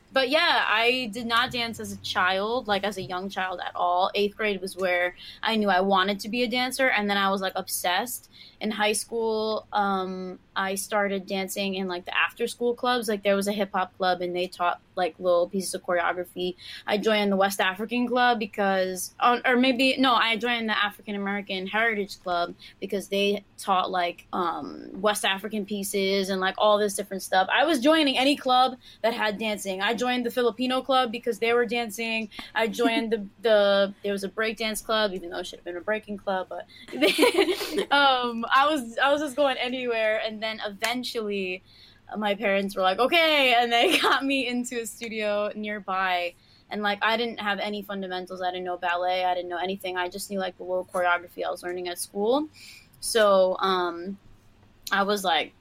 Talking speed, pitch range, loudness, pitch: 200 wpm, 190-235 Hz, -25 LUFS, 205 Hz